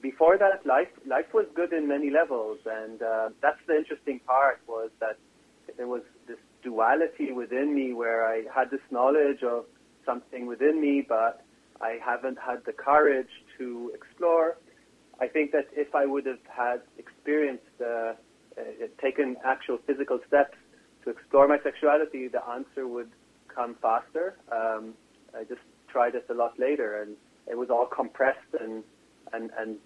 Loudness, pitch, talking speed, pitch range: -28 LUFS, 130 Hz, 160 wpm, 115-150 Hz